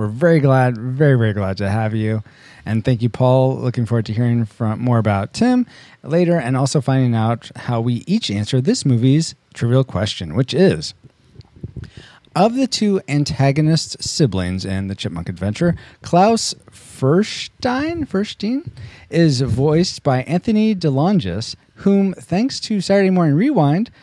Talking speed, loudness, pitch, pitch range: 145 wpm, -18 LUFS, 135 Hz, 115-175 Hz